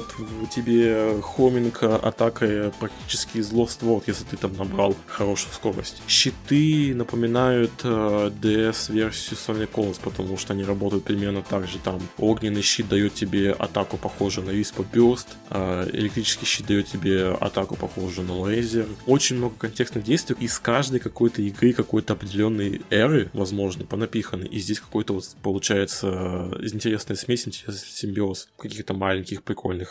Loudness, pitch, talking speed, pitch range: -24 LUFS, 105 Hz, 140 wpm, 100-115 Hz